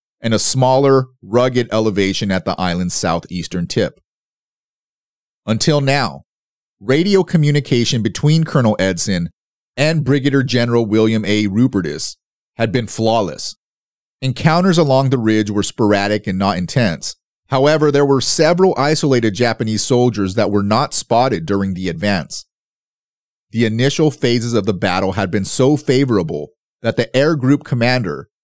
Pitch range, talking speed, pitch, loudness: 105-135 Hz, 135 wpm, 115 Hz, -16 LUFS